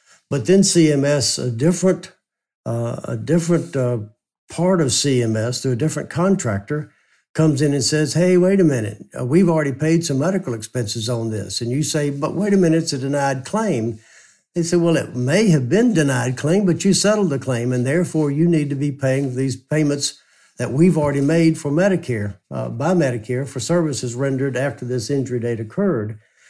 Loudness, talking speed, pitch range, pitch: -19 LUFS, 190 wpm, 125-170 Hz, 145 Hz